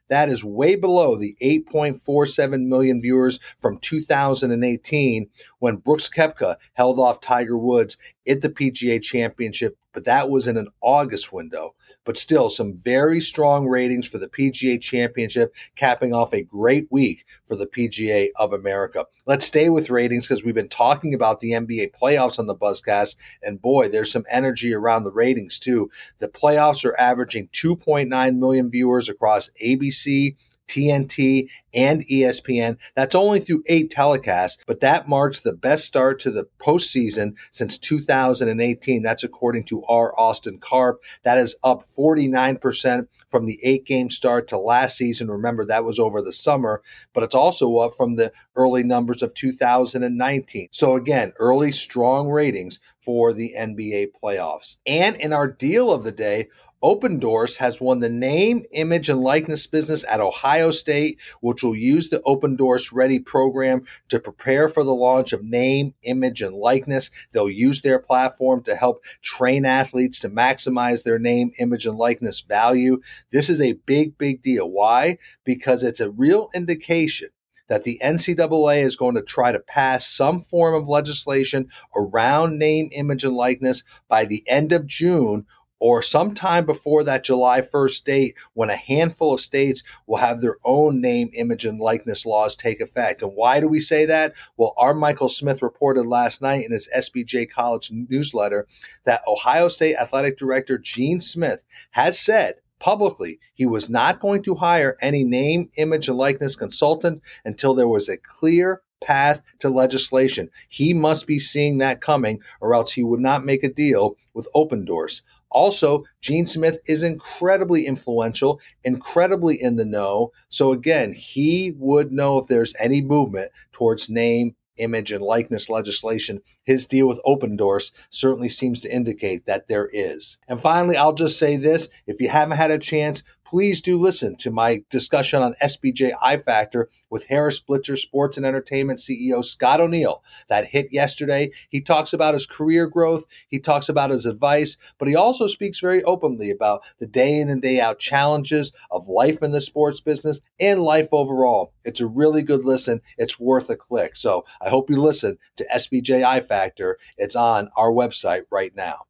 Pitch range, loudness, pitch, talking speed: 120-150 Hz, -20 LUFS, 135 Hz, 170 wpm